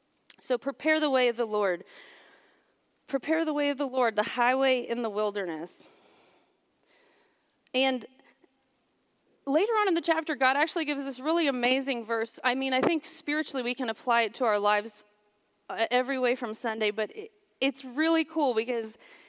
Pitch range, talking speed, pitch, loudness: 230-310 Hz, 160 wpm, 260 Hz, -28 LUFS